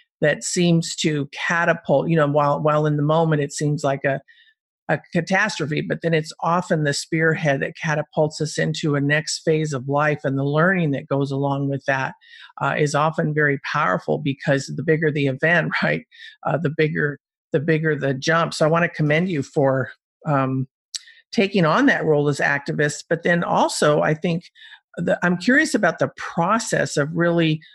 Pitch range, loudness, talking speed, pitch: 145-170 Hz, -21 LUFS, 185 wpm, 155 Hz